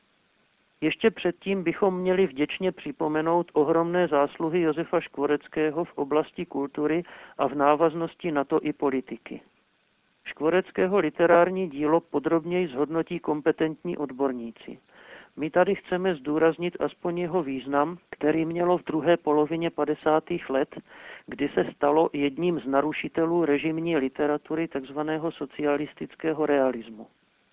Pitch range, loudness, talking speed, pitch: 145-170 Hz, -26 LUFS, 115 wpm, 155 Hz